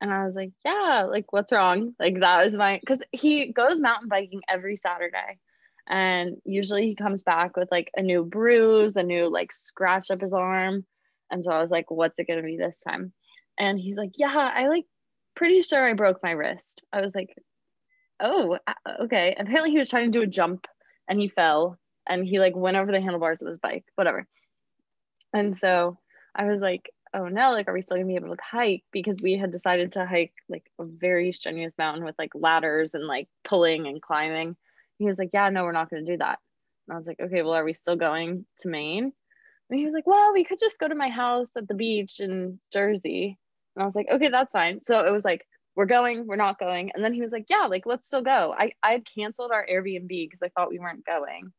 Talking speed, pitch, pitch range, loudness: 230 wpm, 195 Hz, 180-235 Hz, -25 LUFS